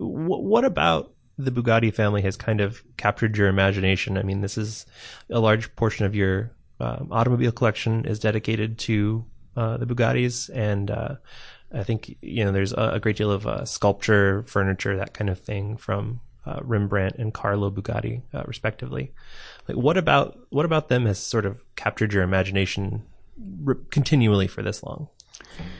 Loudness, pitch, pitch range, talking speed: -24 LUFS, 110 Hz, 100-120 Hz, 165 wpm